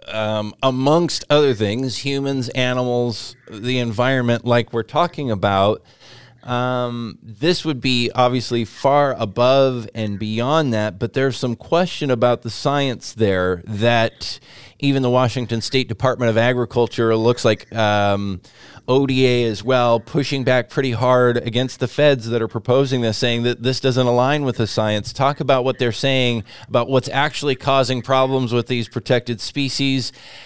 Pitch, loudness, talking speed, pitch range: 125 Hz, -19 LUFS, 150 wpm, 115-135 Hz